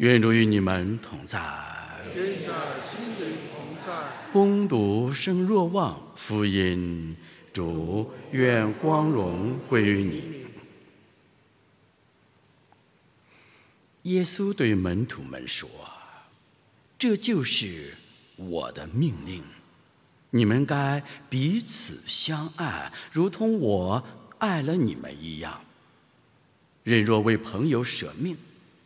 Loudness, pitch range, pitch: -26 LUFS, 105-170 Hz, 125 Hz